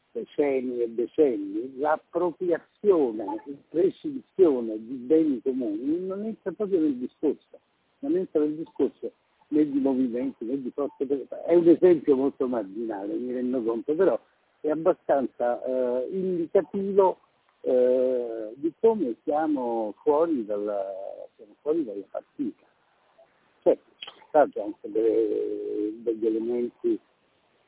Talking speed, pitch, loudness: 110 wpm, 155 Hz, -26 LUFS